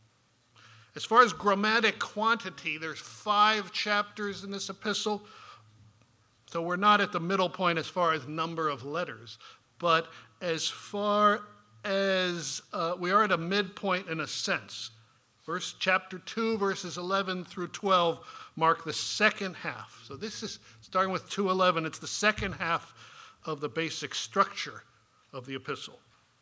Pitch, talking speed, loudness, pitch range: 180 Hz, 150 wpm, -29 LUFS, 150-200 Hz